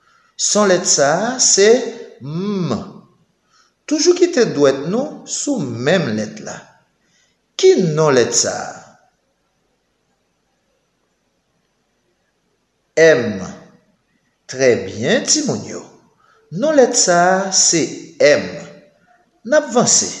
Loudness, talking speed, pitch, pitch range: -15 LUFS, 85 wpm, 225 Hz, 180-290 Hz